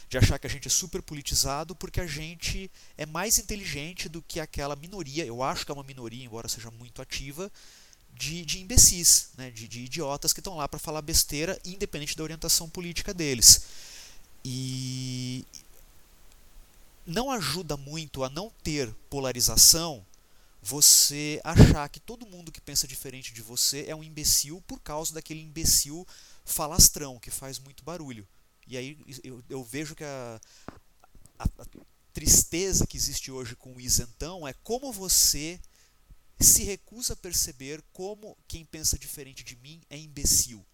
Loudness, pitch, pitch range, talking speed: -24 LUFS, 145 Hz, 130-165 Hz, 160 wpm